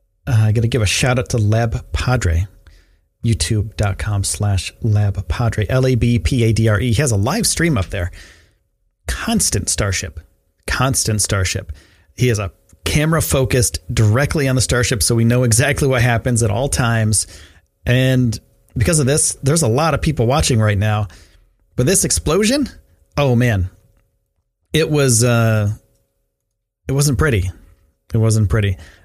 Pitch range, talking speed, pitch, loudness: 95-125 Hz, 145 wpm, 110 Hz, -17 LUFS